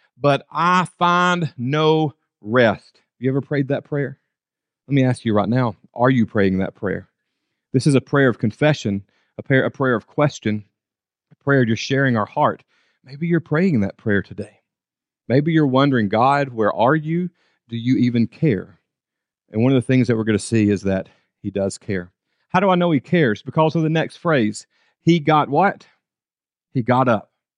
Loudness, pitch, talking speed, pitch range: -19 LUFS, 130 Hz, 195 wpm, 105-150 Hz